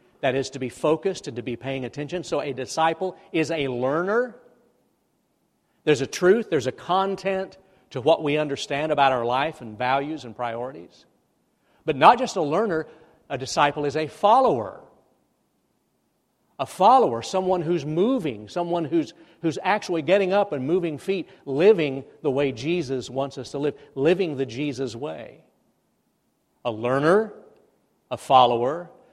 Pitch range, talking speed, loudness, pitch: 135-180 Hz, 150 wpm, -23 LUFS, 155 Hz